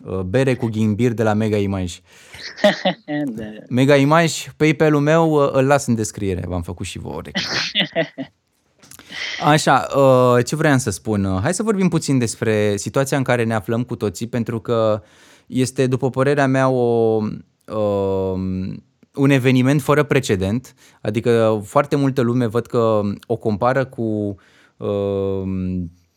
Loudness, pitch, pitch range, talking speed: -19 LUFS, 115 Hz, 105-135 Hz, 140 wpm